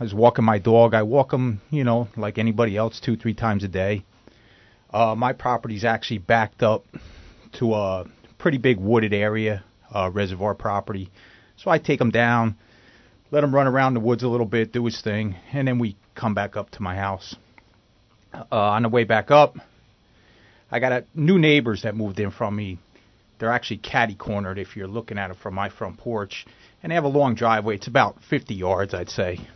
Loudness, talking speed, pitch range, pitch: -22 LUFS, 205 wpm, 105-120 Hz, 115 Hz